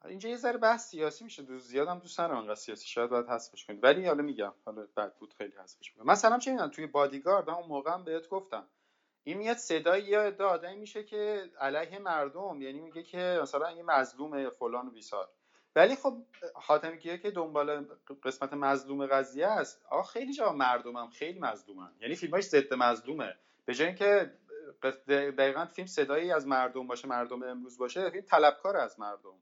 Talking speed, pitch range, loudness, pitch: 175 wpm, 130-195 Hz, -32 LUFS, 155 Hz